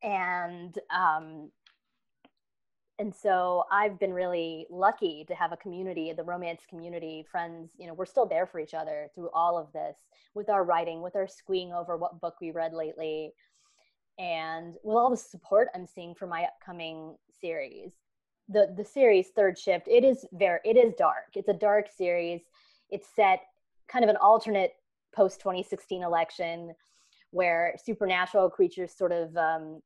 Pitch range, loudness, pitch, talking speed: 170-200 Hz, -28 LUFS, 180 Hz, 165 wpm